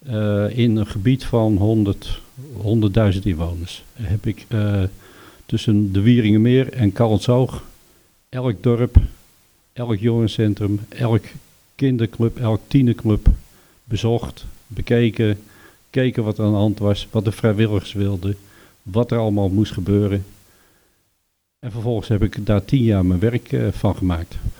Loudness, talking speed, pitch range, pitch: -19 LUFS, 130 wpm, 100-115 Hz, 105 Hz